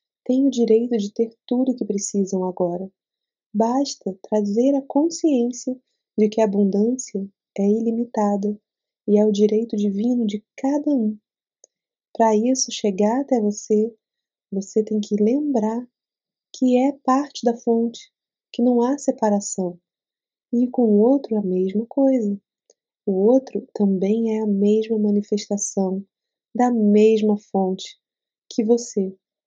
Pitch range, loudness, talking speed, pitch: 205-245 Hz, -21 LUFS, 130 wpm, 220 Hz